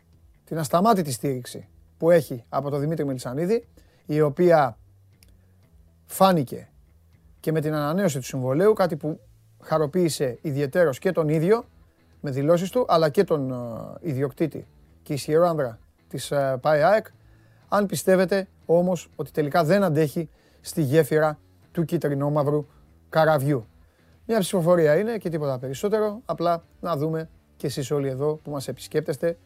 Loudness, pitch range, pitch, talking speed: -24 LUFS, 120-170 Hz, 150 Hz, 135 wpm